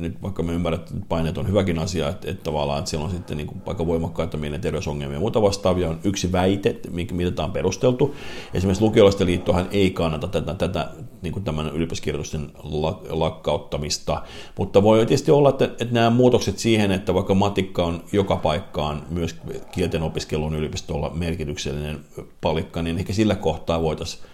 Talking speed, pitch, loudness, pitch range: 170 wpm, 85 Hz, -23 LUFS, 80-100 Hz